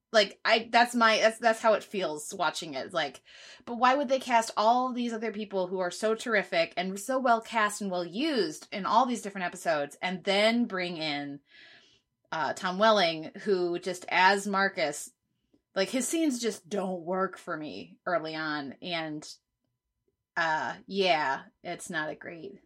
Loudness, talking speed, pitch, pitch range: -28 LUFS, 170 wpm, 200 Hz, 175-230 Hz